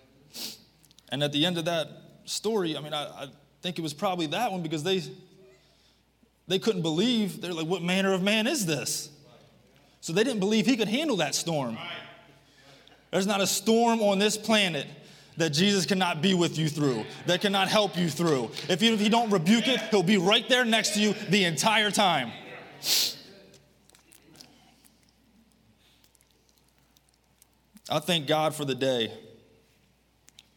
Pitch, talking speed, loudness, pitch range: 180 Hz, 160 wpm, -26 LUFS, 155-205 Hz